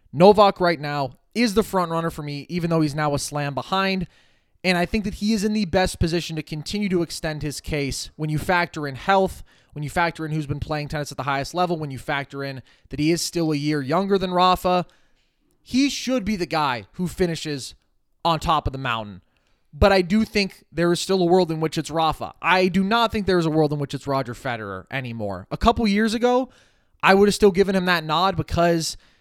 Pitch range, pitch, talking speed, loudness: 145-190 Hz, 165 Hz, 235 wpm, -22 LUFS